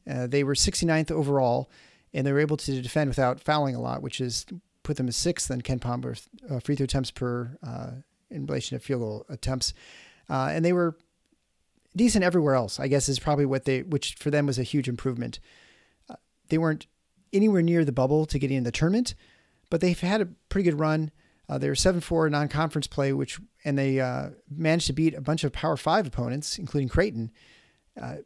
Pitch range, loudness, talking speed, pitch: 130-165 Hz, -27 LUFS, 210 wpm, 145 Hz